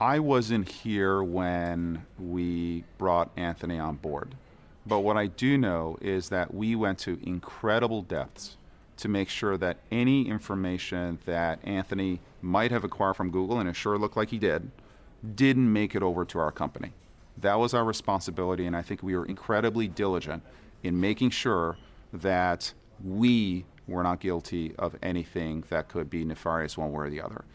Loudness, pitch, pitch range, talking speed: -29 LUFS, 95 Hz, 85-110 Hz, 170 wpm